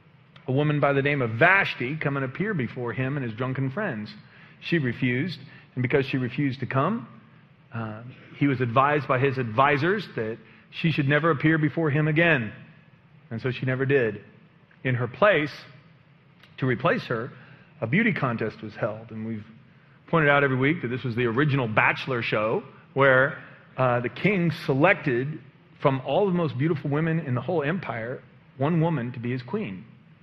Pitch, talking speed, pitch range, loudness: 145 Hz, 175 wpm, 125-155 Hz, -25 LUFS